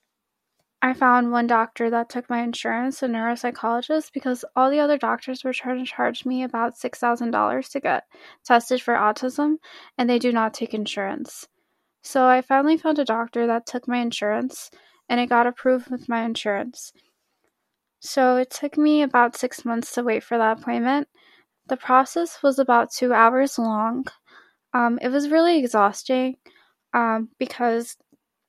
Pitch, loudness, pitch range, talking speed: 250 Hz, -22 LUFS, 235-280 Hz, 160 wpm